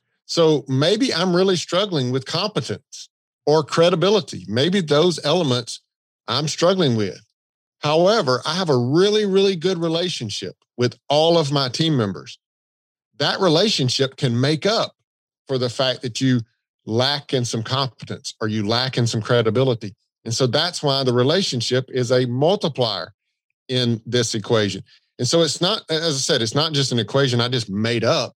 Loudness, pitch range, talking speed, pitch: -20 LUFS, 120-165 Hz, 165 wpm, 135 Hz